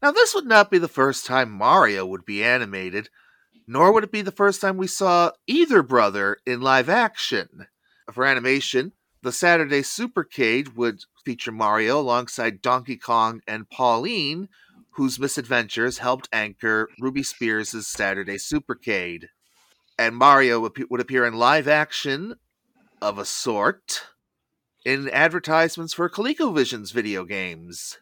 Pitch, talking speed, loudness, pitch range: 130 Hz, 135 wpm, -21 LUFS, 115-170 Hz